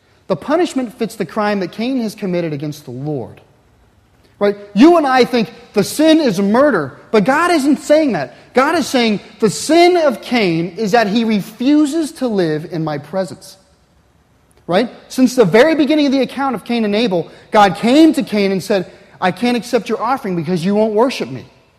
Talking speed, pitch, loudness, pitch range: 195 wpm, 225 Hz, -15 LUFS, 195-265 Hz